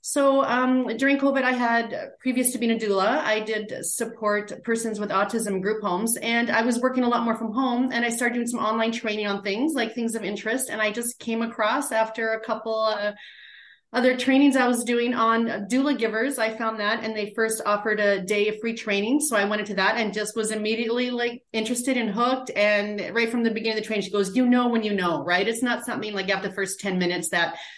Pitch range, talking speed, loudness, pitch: 210-240 Hz, 235 wpm, -24 LUFS, 225 Hz